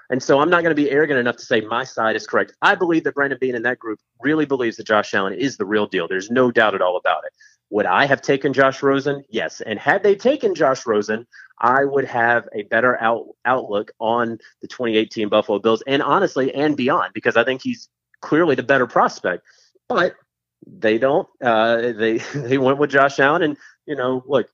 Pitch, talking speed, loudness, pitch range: 130 Hz, 225 wpm, -19 LUFS, 115-145 Hz